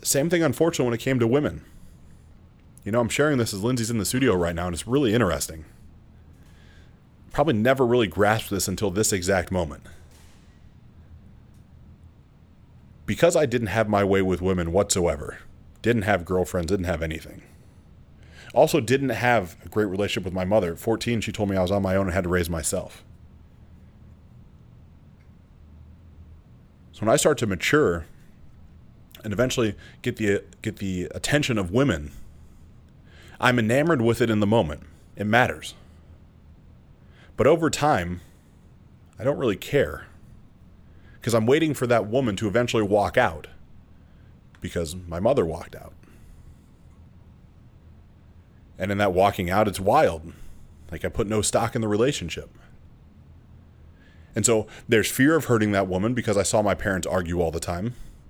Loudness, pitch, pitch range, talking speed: -23 LUFS, 100 Hz, 85-115 Hz, 155 wpm